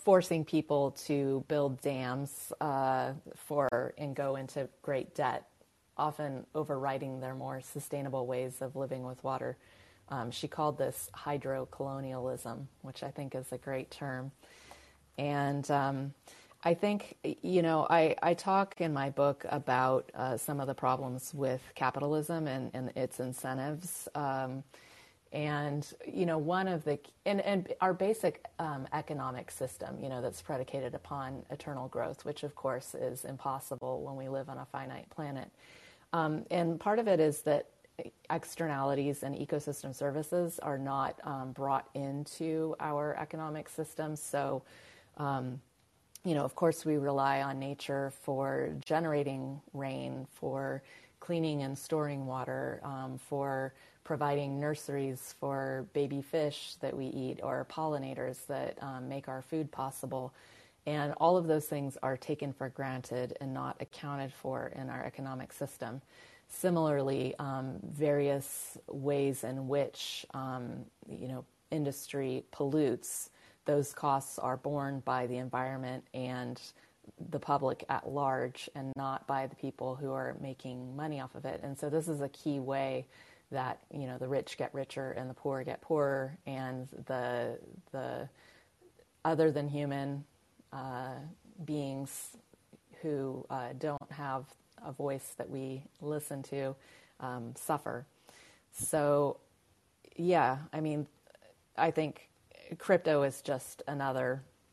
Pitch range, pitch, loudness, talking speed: 130-150 Hz, 140 Hz, -36 LUFS, 140 wpm